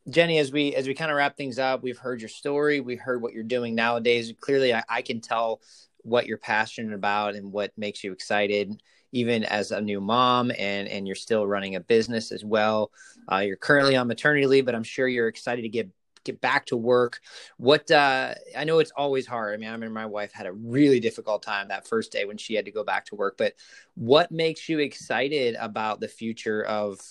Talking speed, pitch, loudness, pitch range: 230 wpm, 115 Hz, -25 LUFS, 105-135 Hz